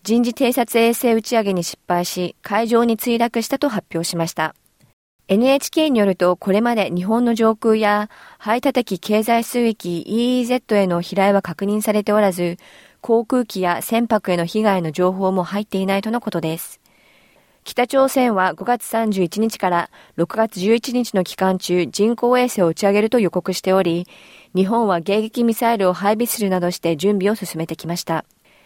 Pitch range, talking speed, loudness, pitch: 180-230 Hz, 320 characters per minute, -19 LUFS, 210 Hz